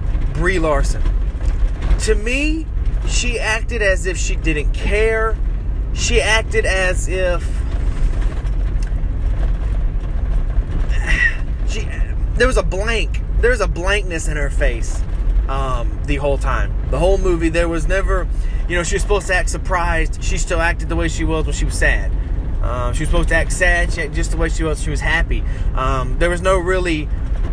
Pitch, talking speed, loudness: 130 Hz, 170 wpm, -19 LUFS